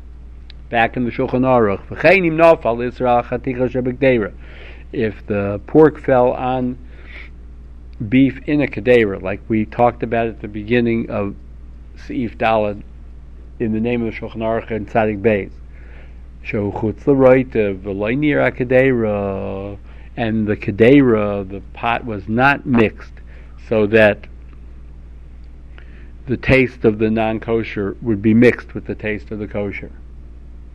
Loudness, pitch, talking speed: -17 LUFS, 105 Hz, 115 wpm